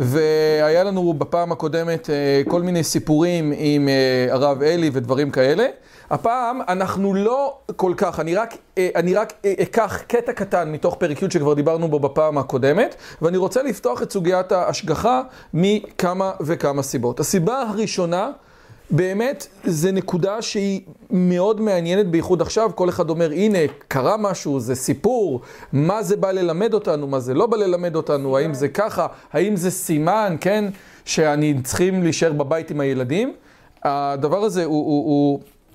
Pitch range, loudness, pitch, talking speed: 150-195 Hz, -20 LUFS, 175 Hz, 150 wpm